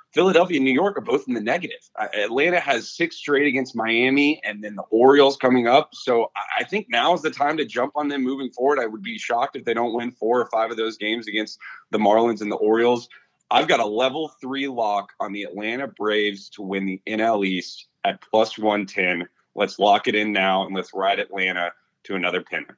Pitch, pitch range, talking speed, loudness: 115 Hz, 105-135 Hz, 220 wpm, -22 LUFS